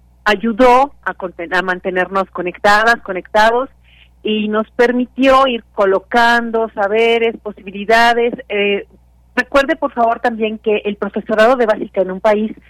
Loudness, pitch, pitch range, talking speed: -14 LUFS, 220 Hz, 200-235 Hz, 130 wpm